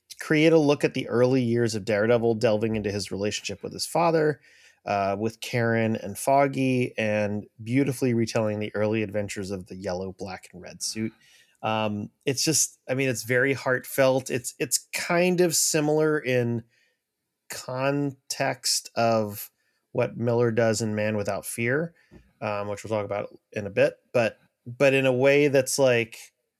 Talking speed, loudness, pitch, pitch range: 160 wpm, -25 LUFS, 120 Hz, 105-135 Hz